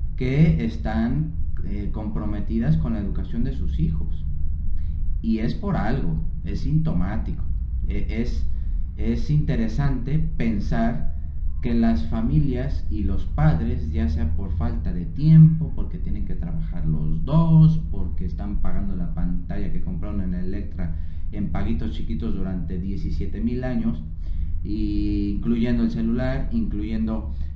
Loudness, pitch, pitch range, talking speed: -25 LUFS, 80 Hz, 75-100 Hz, 130 wpm